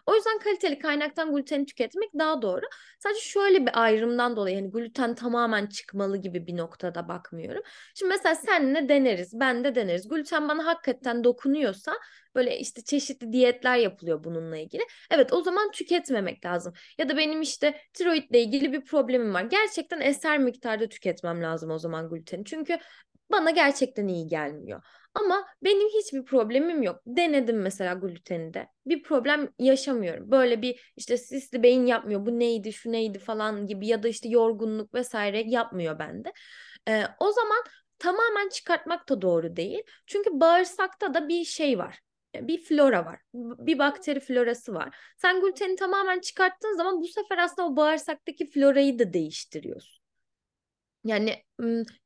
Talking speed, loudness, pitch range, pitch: 150 wpm, -26 LUFS, 220-335 Hz, 265 Hz